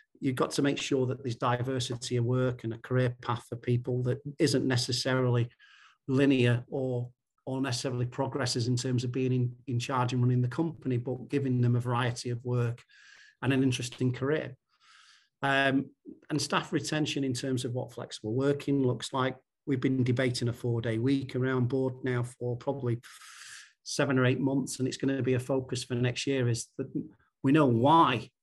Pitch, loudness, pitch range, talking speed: 130 Hz, -30 LUFS, 125-135 Hz, 190 wpm